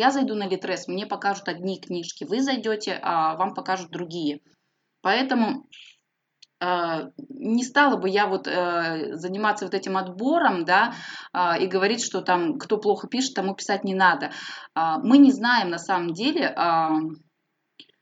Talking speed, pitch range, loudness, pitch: 140 wpm, 175-230 Hz, -24 LUFS, 190 Hz